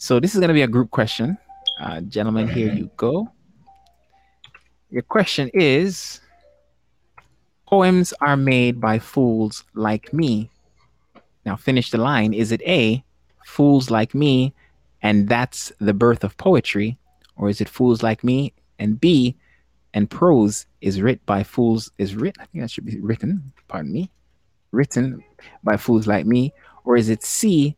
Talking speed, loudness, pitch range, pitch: 160 wpm, -20 LUFS, 105-140 Hz, 115 Hz